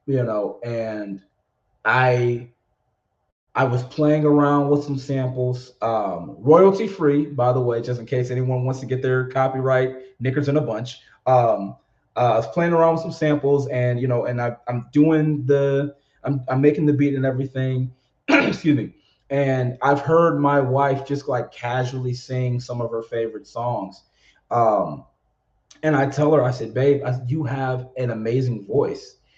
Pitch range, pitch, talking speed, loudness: 125-140 Hz, 130 Hz, 170 wpm, -21 LUFS